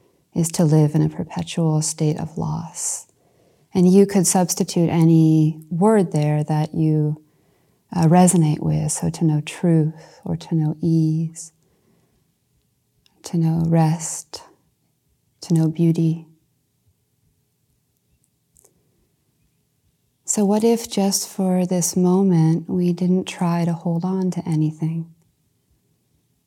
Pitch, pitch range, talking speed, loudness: 165 Hz, 155-180 Hz, 115 wpm, -19 LUFS